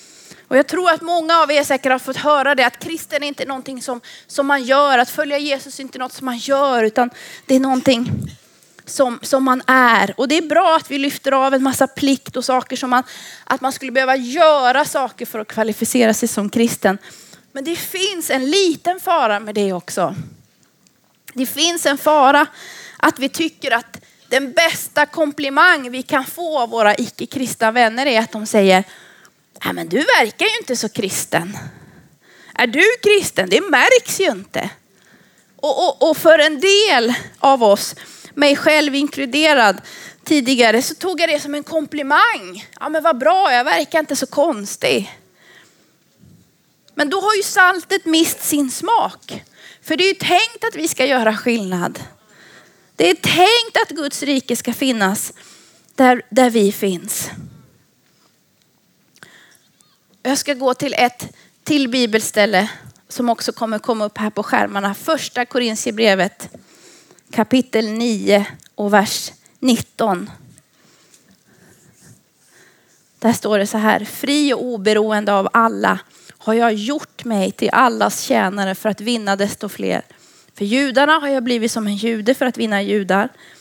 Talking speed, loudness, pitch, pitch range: 160 wpm, -16 LUFS, 260 Hz, 220-300 Hz